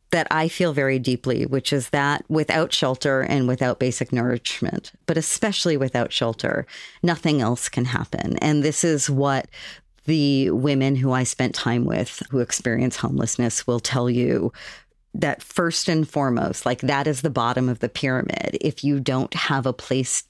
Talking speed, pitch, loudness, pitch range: 170 wpm, 135 Hz, -22 LUFS, 125-150 Hz